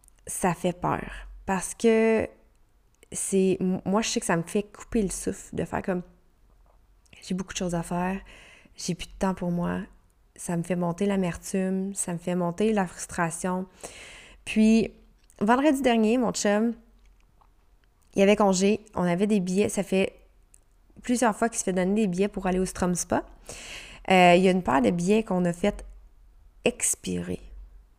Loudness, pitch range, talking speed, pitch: -26 LUFS, 175-210 Hz, 175 wpm, 190 Hz